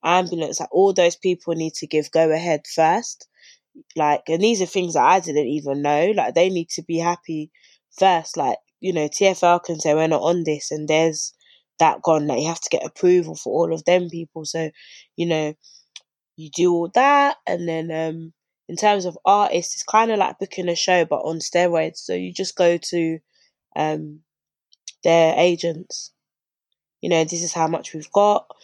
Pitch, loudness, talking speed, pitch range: 170 Hz, -20 LUFS, 195 wpm, 160-180 Hz